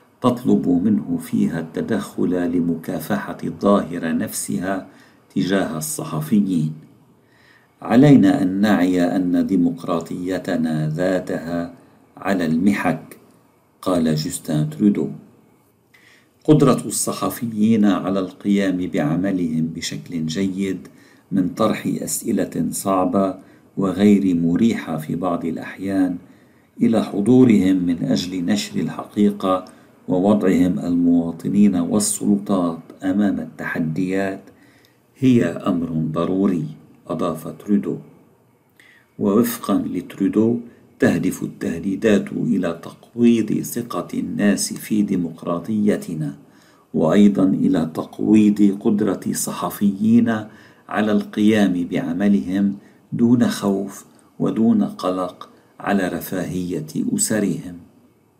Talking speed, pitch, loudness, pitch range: 80 wpm, 95 Hz, -20 LUFS, 90-110 Hz